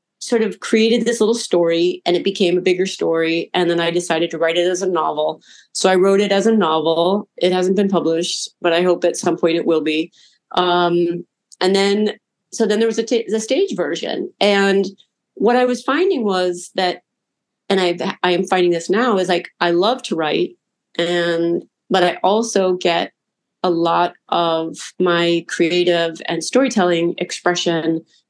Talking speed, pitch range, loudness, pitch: 185 wpm, 170-200 Hz, -18 LUFS, 180 Hz